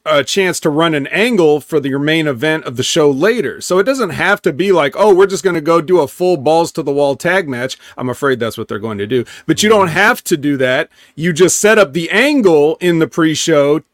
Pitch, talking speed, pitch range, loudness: 165 Hz, 265 wpm, 145-190 Hz, -13 LUFS